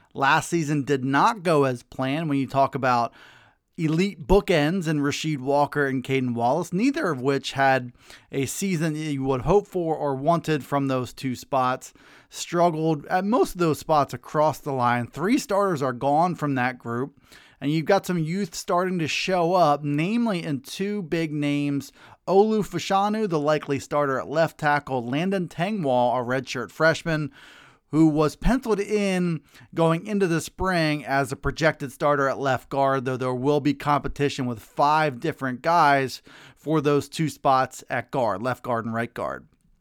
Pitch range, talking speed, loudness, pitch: 135-170 Hz, 170 wpm, -24 LUFS, 145 Hz